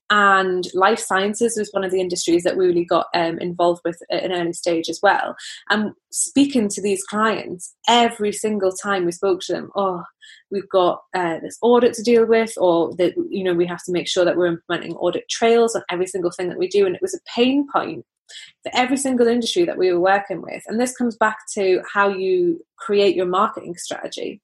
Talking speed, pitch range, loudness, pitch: 220 wpm, 180-230 Hz, -20 LUFS, 195 Hz